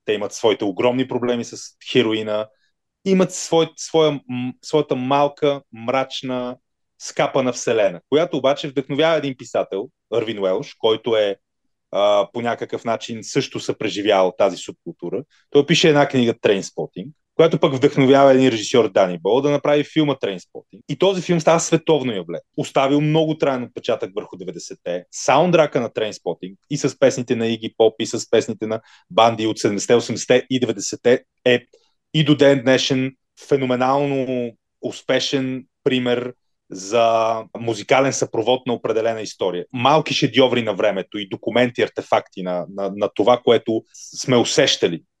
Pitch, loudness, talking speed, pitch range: 130 Hz, -19 LUFS, 140 wpm, 115-145 Hz